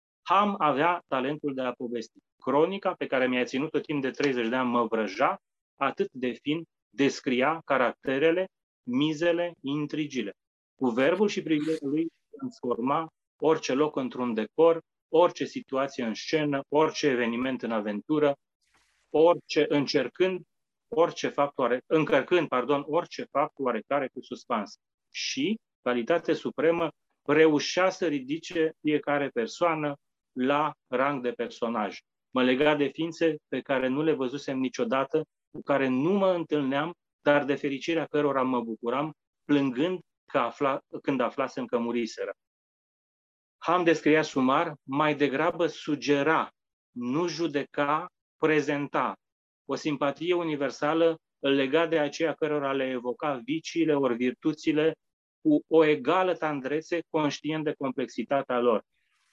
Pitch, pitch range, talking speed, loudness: 150 Hz, 130-160 Hz, 125 wpm, -27 LUFS